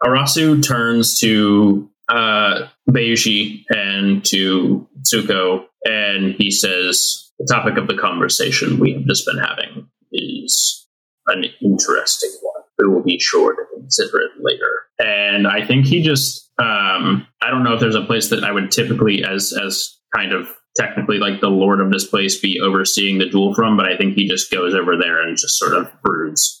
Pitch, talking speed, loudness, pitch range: 105 Hz, 175 wpm, -16 LUFS, 100-135 Hz